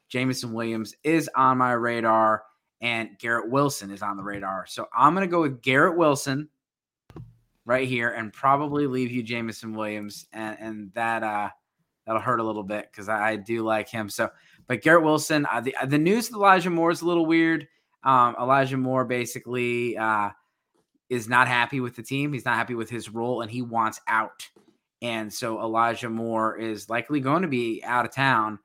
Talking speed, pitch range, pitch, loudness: 190 wpm, 110-135 Hz, 120 Hz, -24 LUFS